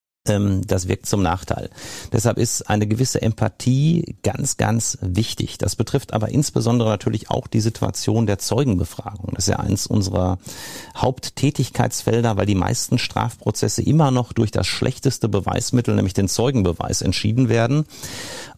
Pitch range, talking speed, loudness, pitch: 105-125 Hz, 140 wpm, -20 LUFS, 115 Hz